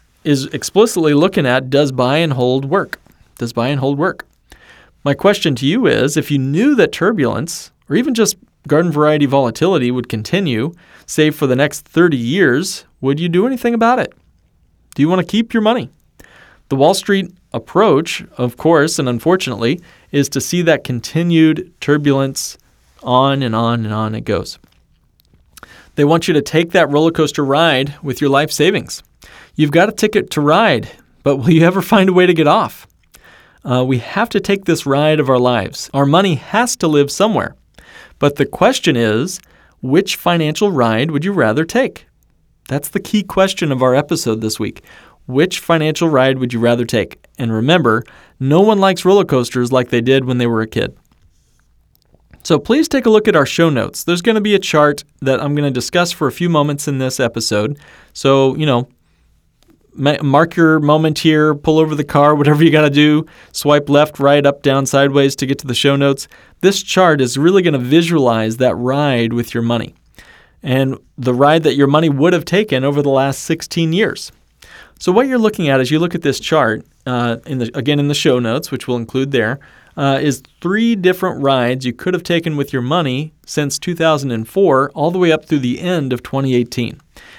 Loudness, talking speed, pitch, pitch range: -14 LUFS, 195 wpm, 145 Hz, 130-170 Hz